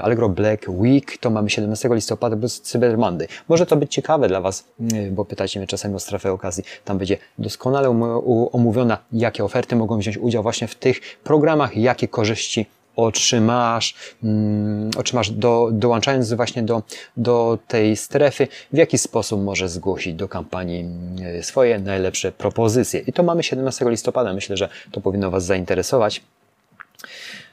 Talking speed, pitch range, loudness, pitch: 155 wpm, 100-125 Hz, -20 LUFS, 115 Hz